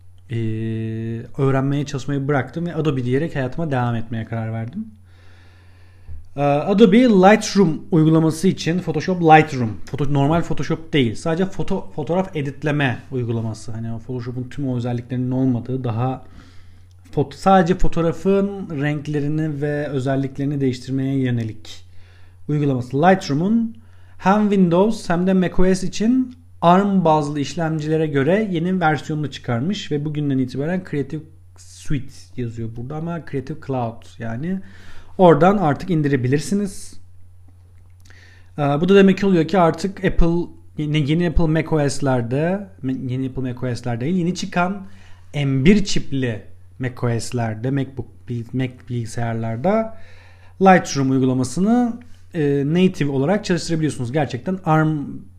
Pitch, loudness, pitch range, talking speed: 140 Hz, -20 LUFS, 115-170 Hz, 115 wpm